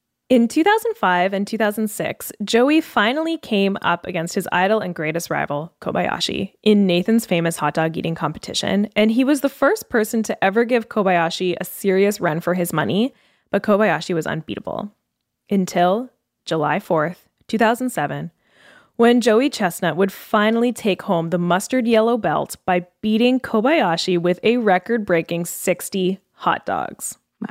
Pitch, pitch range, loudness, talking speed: 200 Hz, 175-235 Hz, -19 LUFS, 145 wpm